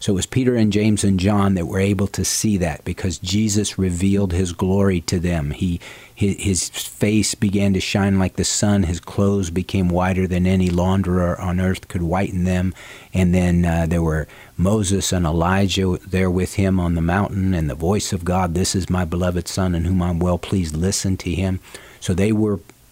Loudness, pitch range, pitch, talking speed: -20 LUFS, 90-100 Hz, 95 Hz, 205 wpm